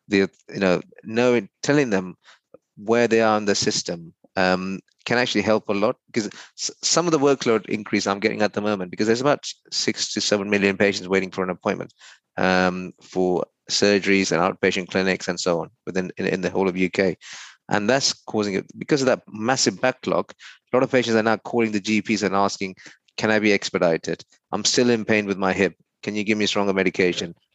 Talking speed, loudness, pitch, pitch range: 205 wpm, -22 LUFS, 100 Hz, 95-110 Hz